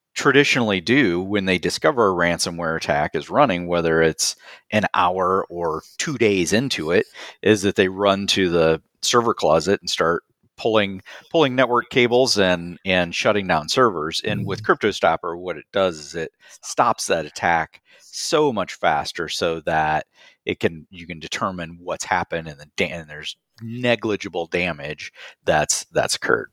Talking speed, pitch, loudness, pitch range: 160 wpm, 90 Hz, -20 LUFS, 80-110 Hz